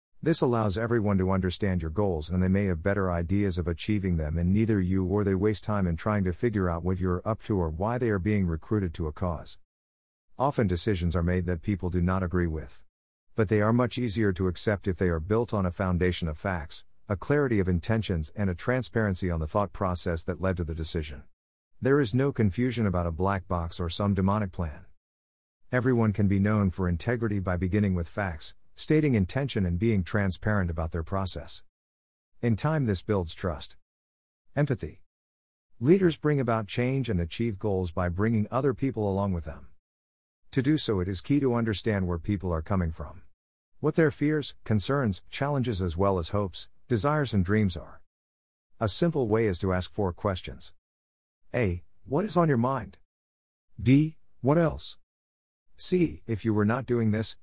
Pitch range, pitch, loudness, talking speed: 85-110 Hz, 95 Hz, -28 LUFS, 190 wpm